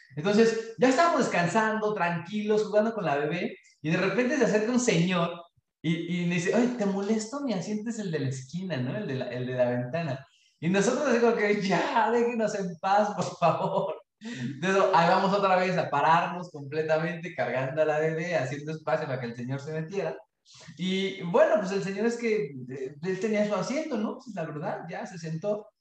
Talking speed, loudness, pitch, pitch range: 200 wpm, -27 LUFS, 185 Hz, 155-215 Hz